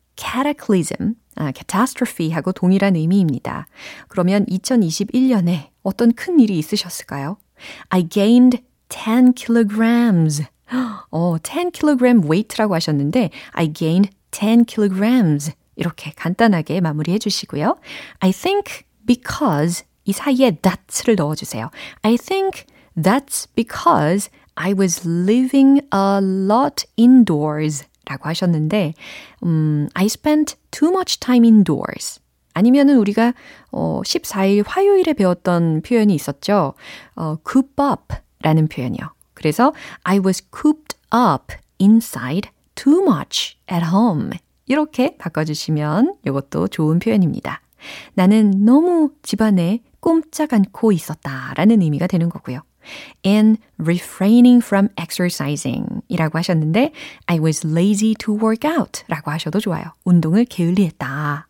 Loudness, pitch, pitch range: -17 LUFS, 200 Hz, 165-245 Hz